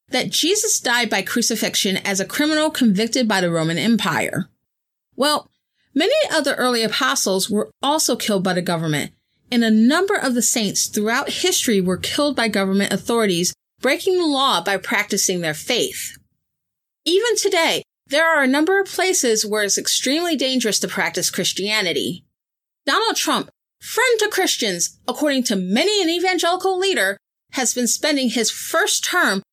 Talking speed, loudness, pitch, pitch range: 155 wpm, -18 LUFS, 240 Hz, 200-315 Hz